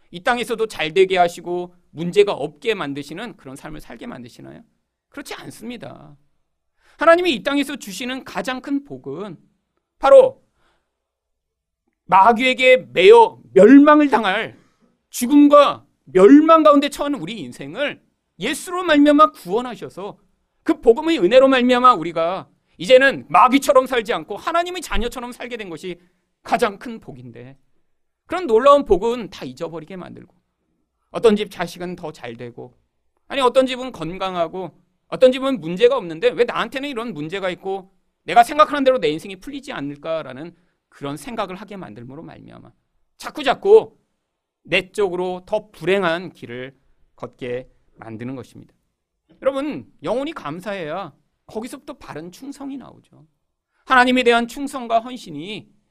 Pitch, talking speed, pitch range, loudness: 210 Hz, 310 characters per minute, 160-270 Hz, -17 LUFS